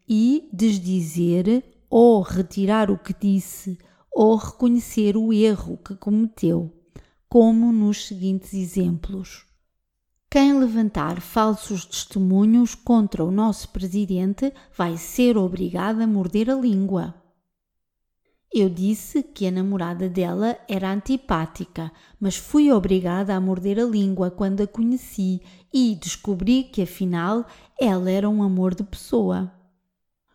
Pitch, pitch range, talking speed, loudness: 195 Hz, 185-225 Hz, 120 wpm, -21 LUFS